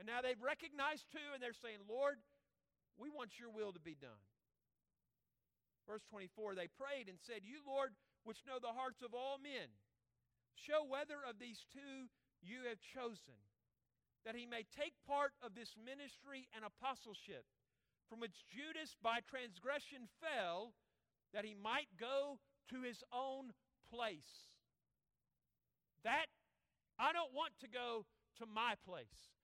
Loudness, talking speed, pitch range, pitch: -48 LUFS, 145 wpm, 215-275 Hz, 240 Hz